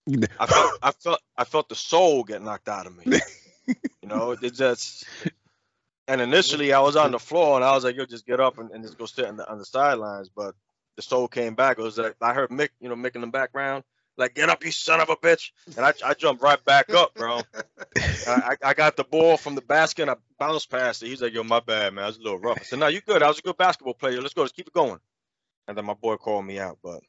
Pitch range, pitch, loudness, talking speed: 120-150 Hz, 130 Hz, -23 LUFS, 275 wpm